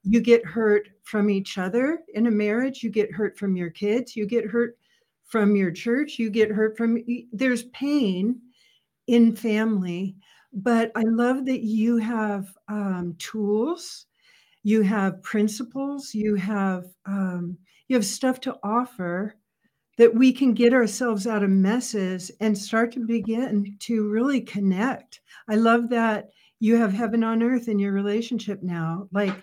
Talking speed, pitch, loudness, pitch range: 155 wpm, 220 Hz, -24 LUFS, 205-235 Hz